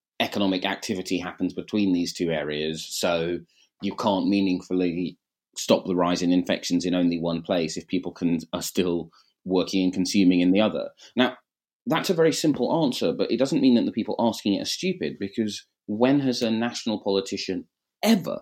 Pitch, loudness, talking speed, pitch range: 95 Hz, -25 LUFS, 180 wpm, 90-105 Hz